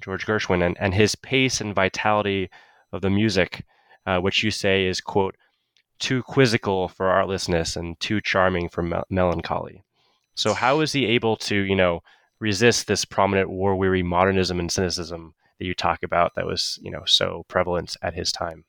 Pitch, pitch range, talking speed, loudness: 95 Hz, 90-105 Hz, 180 wpm, -22 LUFS